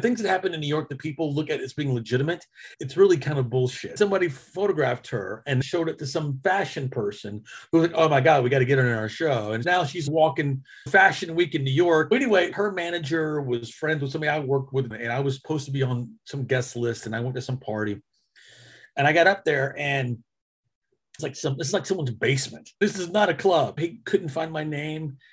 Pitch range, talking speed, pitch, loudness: 130-170 Hz, 235 wpm, 150 Hz, -24 LUFS